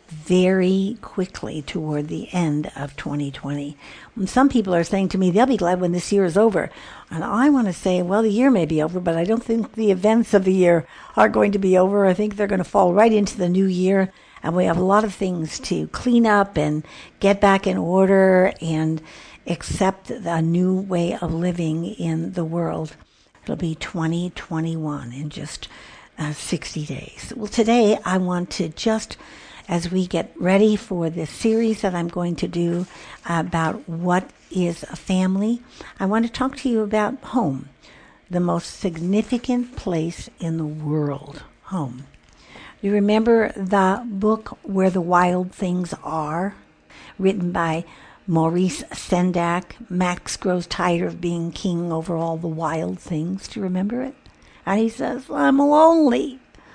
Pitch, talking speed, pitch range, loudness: 185 Hz, 175 wpm, 165-205 Hz, -21 LUFS